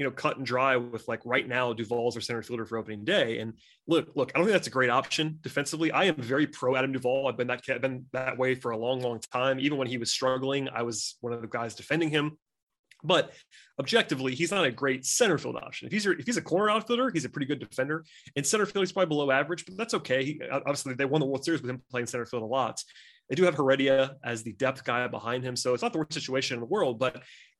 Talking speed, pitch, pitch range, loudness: 270 wpm, 130 Hz, 125-145 Hz, -29 LUFS